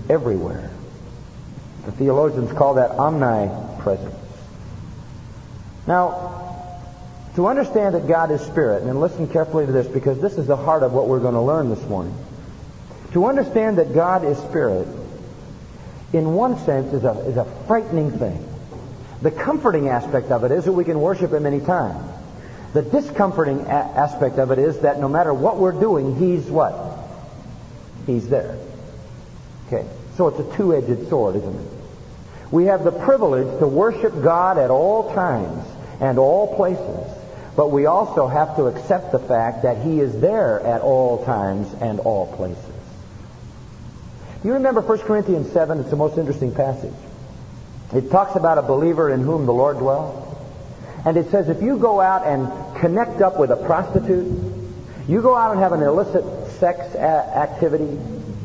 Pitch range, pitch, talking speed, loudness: 130-180 Hz, 150 Hz, 160 wpm, -19 LUFS